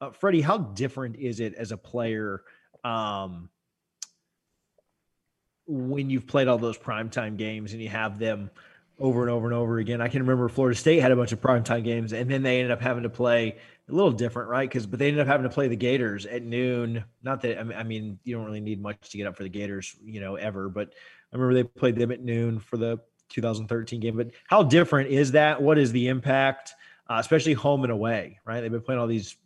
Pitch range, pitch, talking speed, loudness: 110-130 Hz, 120 Hz, 230 wpm, -26 LUFS